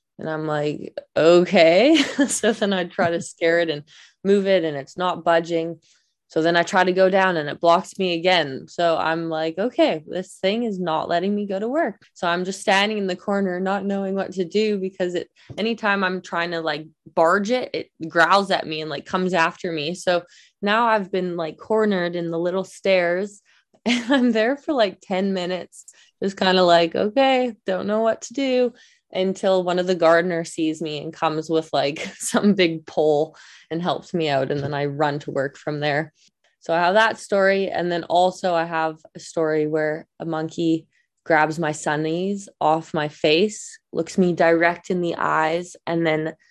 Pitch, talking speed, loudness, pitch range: 175 Hz, 200 wpm, -21 LUFS, 160-195 Hz